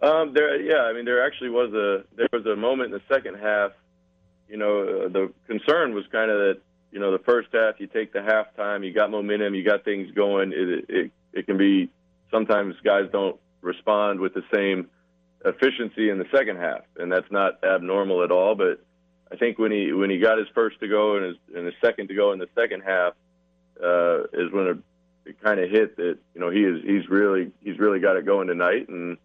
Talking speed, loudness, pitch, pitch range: 225 wpm, -23 LUFS, 100 Hz, 90-110 Hz